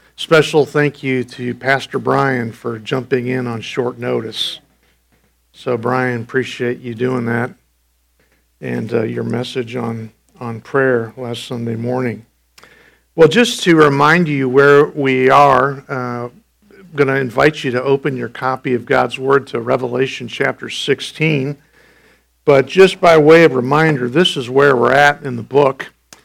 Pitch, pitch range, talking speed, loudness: 130 Hz, 120-145 Hz, 155 wpm, -15 LUFS